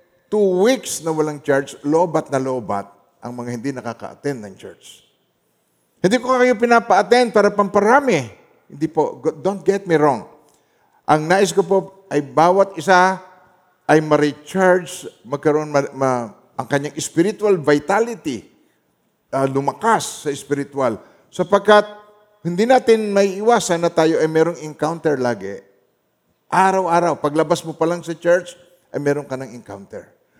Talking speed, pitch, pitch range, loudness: 135 wpm, 165 Hz, 145-195 Hz, -18 LUFS